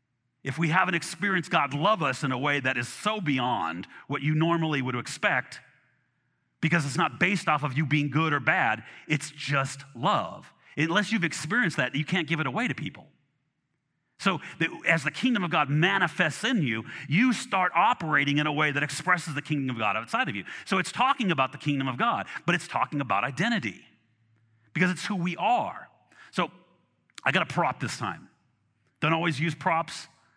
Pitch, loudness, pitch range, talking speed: 155 Hz, -27 LUFS, 140-175 Hz, 190 wpm